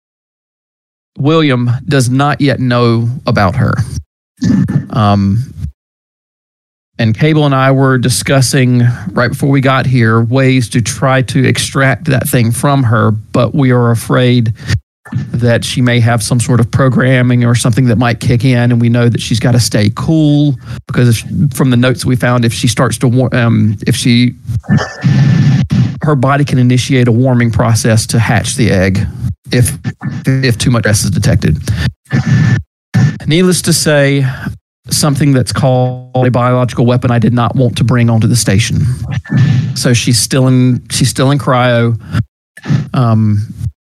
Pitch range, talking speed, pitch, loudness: 120-135 Hz, 155 wpm, 125 Hz, -11 LUFS